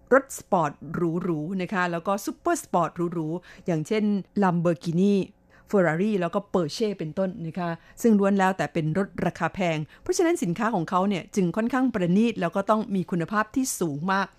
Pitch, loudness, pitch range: 185 Hz, -25 LUFS, 170-210 Hz